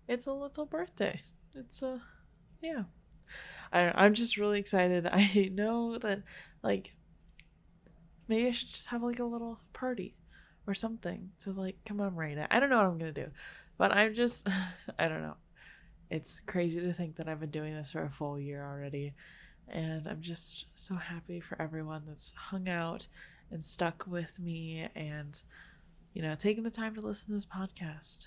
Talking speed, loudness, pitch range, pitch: 185 wpm, -34 LUFS, 160-210 Hz, 180 Hz